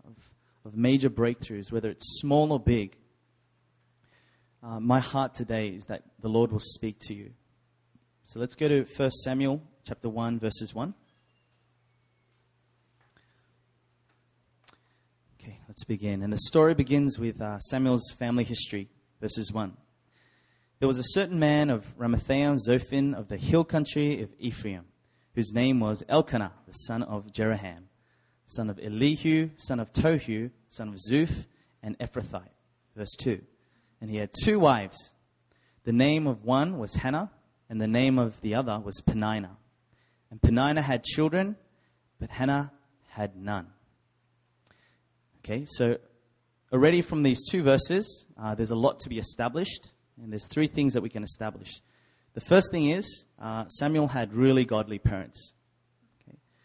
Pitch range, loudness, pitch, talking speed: 110-135 Hz, -28 LUFS, 120 Hz, 145 wpm